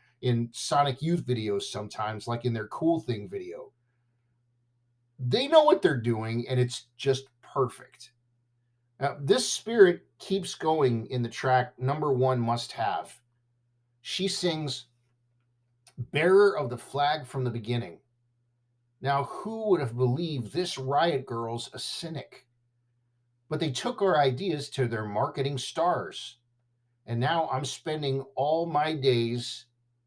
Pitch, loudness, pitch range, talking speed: 125 Hz, -28 LUFS, 120-140 Hz, 135 wpm